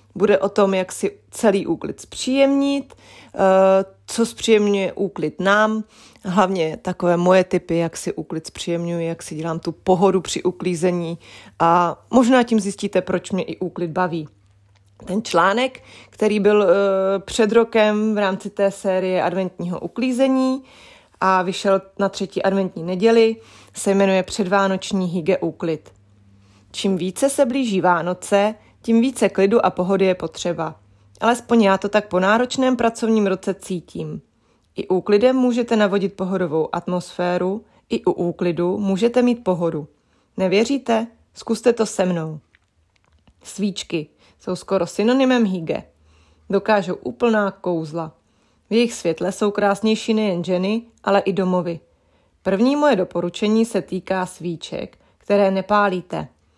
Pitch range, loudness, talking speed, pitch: 175-215 Hz, -20 LUFS, 130 wpm, 190 Hz